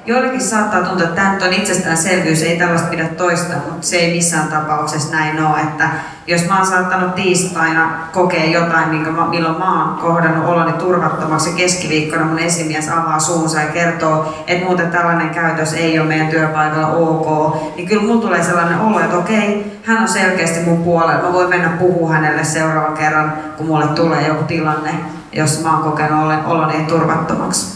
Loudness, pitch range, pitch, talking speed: -15 LUFS, 155-175 Hz, 165 Hz, 175 wpm